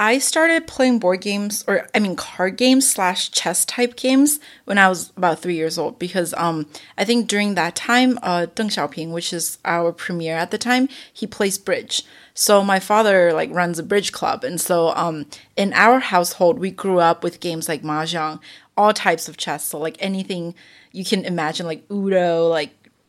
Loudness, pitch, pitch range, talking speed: -19 LUFS, 185 Hz, 170-215 Hz, 195 wpm